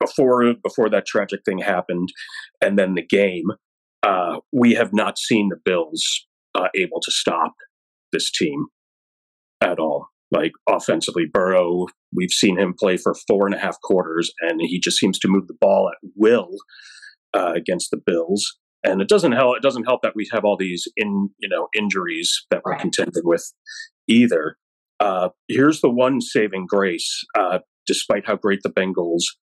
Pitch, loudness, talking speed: 115 Hz, -20 LUFS, 175 wpm